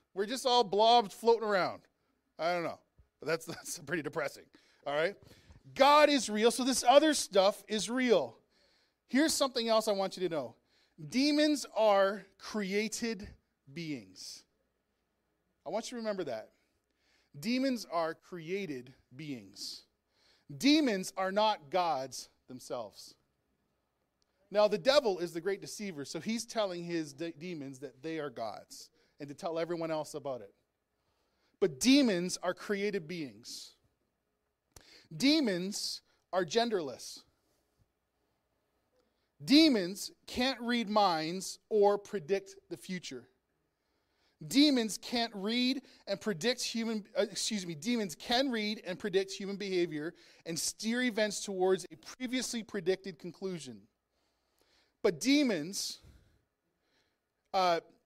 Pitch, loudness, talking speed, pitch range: 200 Hz, -32 LUFS, 125 wpm, 170-235 Hz